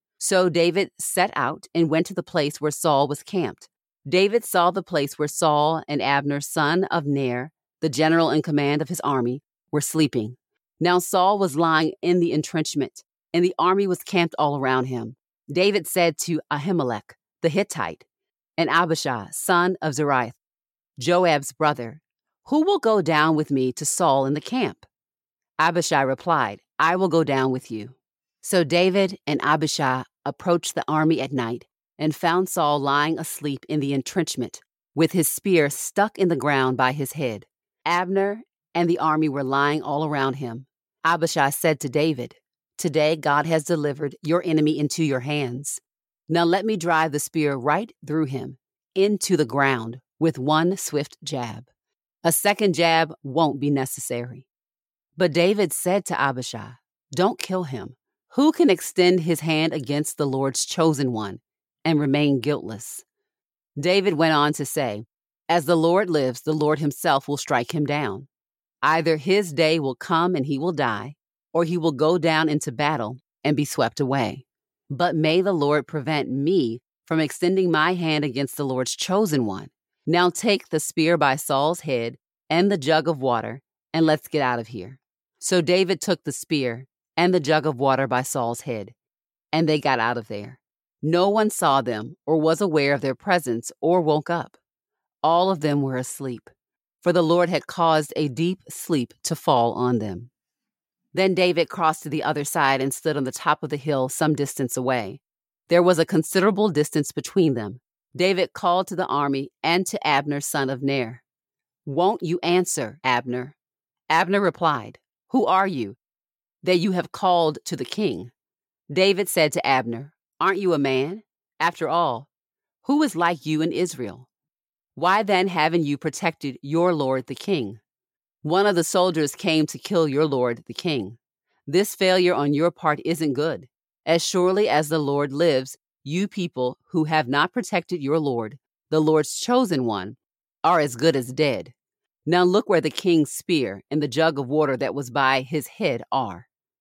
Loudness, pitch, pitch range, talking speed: -22 LUFS, 155 Hz, 140-175 Hz, 175 wpm